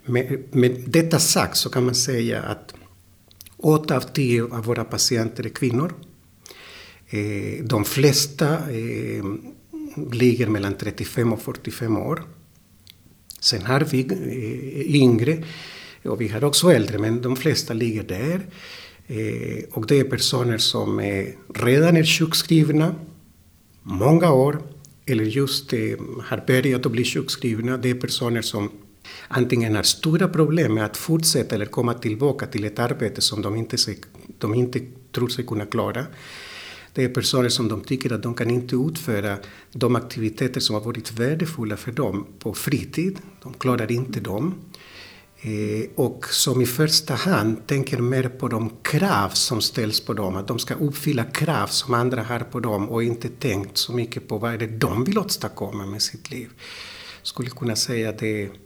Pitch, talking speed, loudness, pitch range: 120 Hz, 165 wpm, -22 LUFS, 110-140 Hz